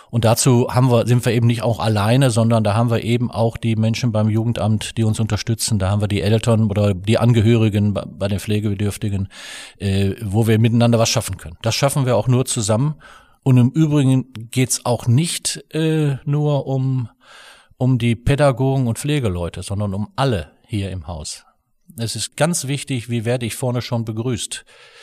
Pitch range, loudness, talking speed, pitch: 105-130 Hz, -18 LUFS, 185 wpm, 115 Hz